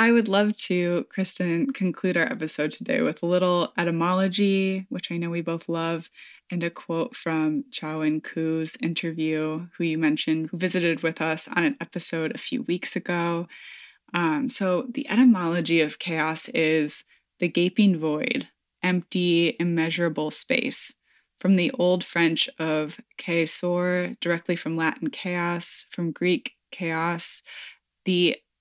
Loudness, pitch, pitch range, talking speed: -24 LUFS, 170 Hz, 165-185 Hz, 145 wpm